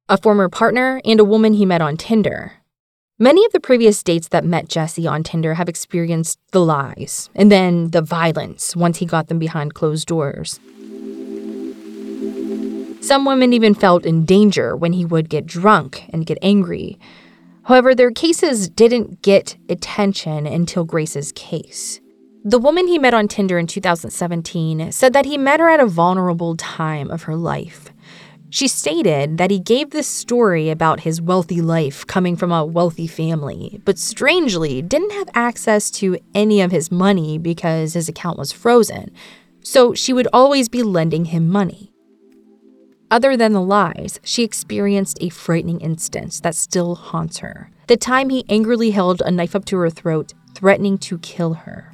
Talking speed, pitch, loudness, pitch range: 170 wpm, 180 Hz, -16 LUFS, 165-215 Hz